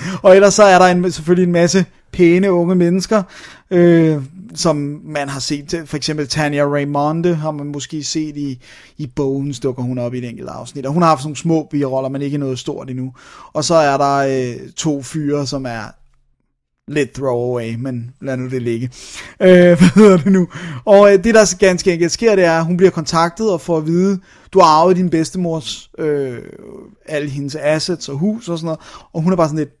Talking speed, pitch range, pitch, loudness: 215 wpm, 140-180 Hz, 155 Hz, -15 LUFS